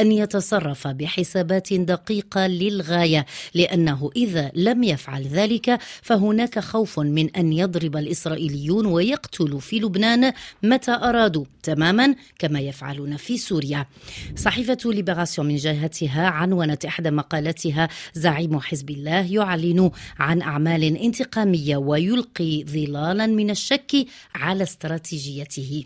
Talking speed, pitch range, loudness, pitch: 105 wpm, 155-210 Hz, -22 LUFS, 175 Hz